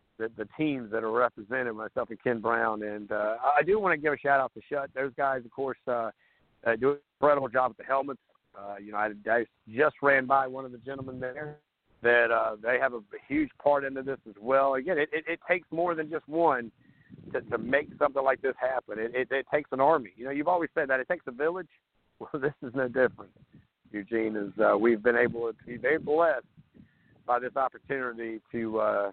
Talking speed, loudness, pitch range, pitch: 225 wpm, -29 LUFS, 115-145 Hz, 130 Hz